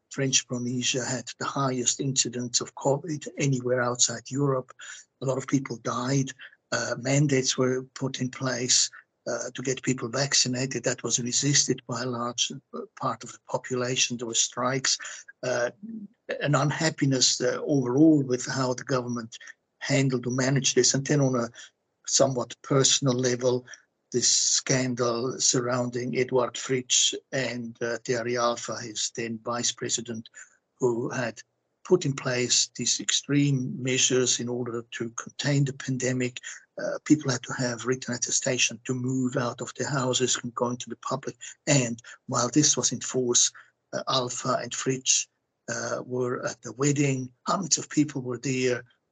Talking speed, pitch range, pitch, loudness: 155 wpm, 120-135 Hz, 125 Hz, -26 LUFS